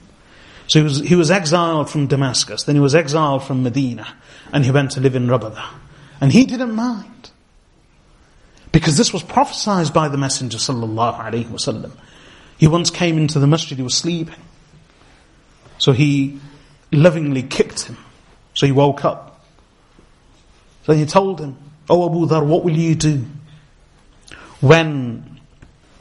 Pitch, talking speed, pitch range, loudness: 145 Hz, 145 wpm, 135-165 Hz, -17 LUFS